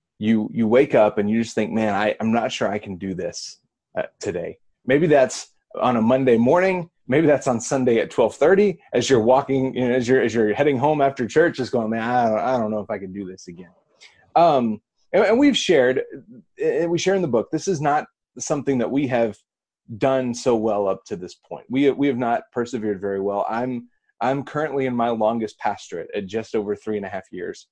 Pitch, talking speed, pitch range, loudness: 125 Hz, 225 wpm, 110-145 Hz, -21 LUFS